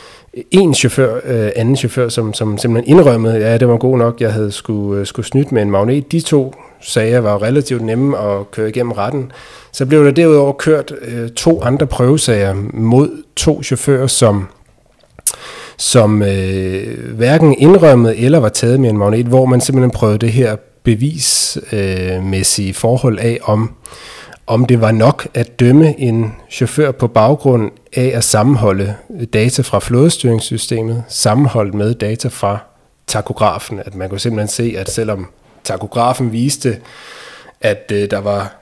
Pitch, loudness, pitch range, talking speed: 120 Hz, -13 LUFS, 105-135 Hz, 150 wpm